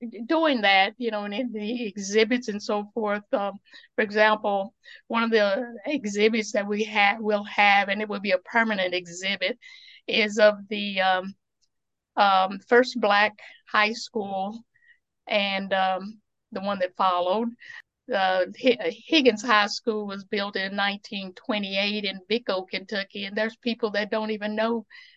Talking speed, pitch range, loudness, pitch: 155 wpm, 200-230 Hz, -24 LUFS, 210 Hz